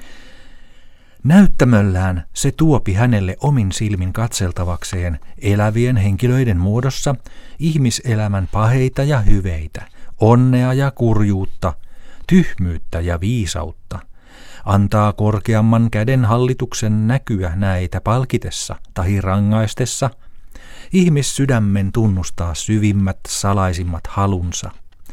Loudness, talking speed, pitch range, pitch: -17 LUFS, 80 wpm, 95-125 Hz, 105 Hz